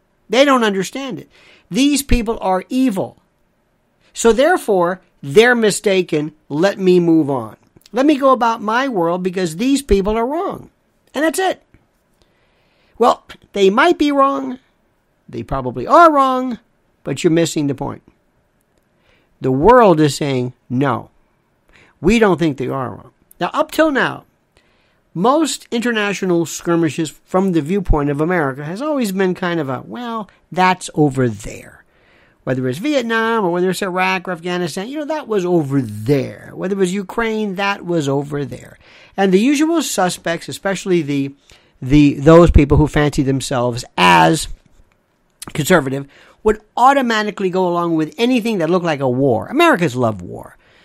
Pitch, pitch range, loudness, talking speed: 185 Hz, 150-230 Hz, -16 LUFS, 150 wpm